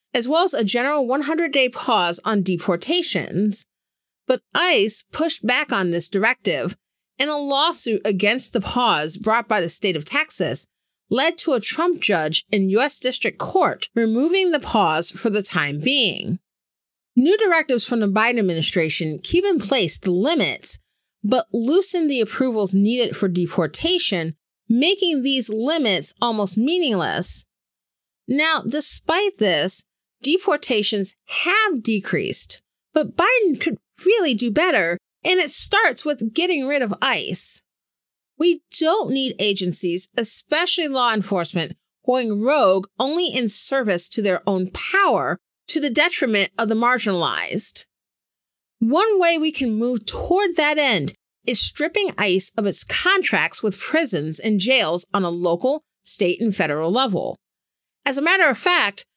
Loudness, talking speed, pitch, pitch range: -18 LUFS, 140 wpm, 245 Hz, 200-310 Hz